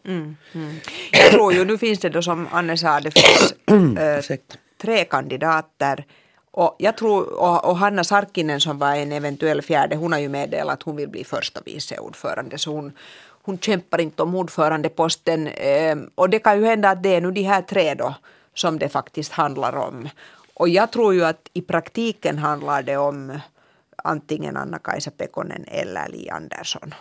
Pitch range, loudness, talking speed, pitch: 150-190 Hz, -19 LUFS, 180 wpm, 165 Hz